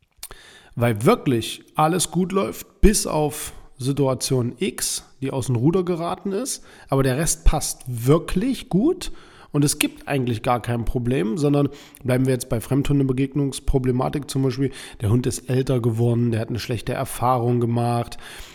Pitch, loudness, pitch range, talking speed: 135 Hz, -22 LUFS, 125-155 Hz, 150 wpm